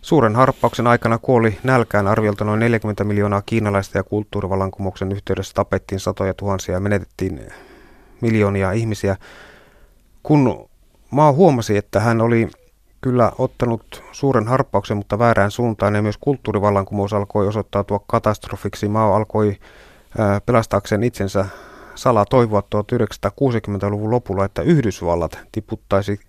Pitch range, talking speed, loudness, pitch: 100-115 Hz, 115 wpm, -19 LUFS, 105 Hz